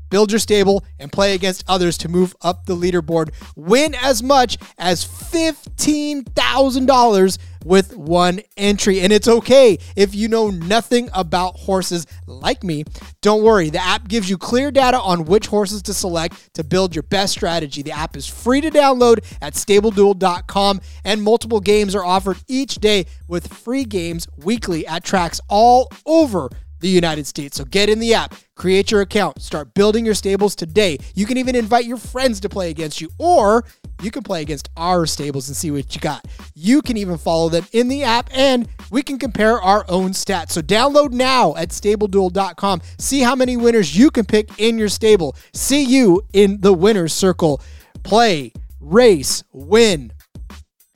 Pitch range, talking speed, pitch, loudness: 175-230 Hz, 175 wpm, 200 Hz, -16 LUFS